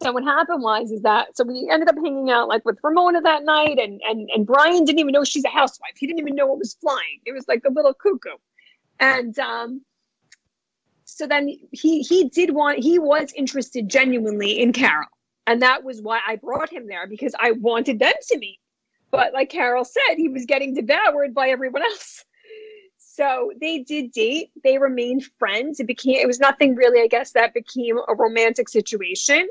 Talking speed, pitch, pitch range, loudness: 200 wpm, 270 Hz, 240-305 Hz, -19 LUFS